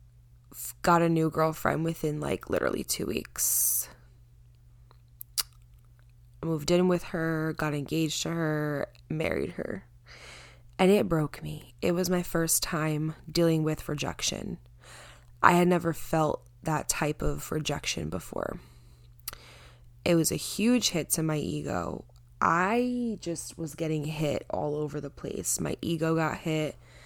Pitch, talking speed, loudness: 155 Hz, 135 wpm, -29 LUFS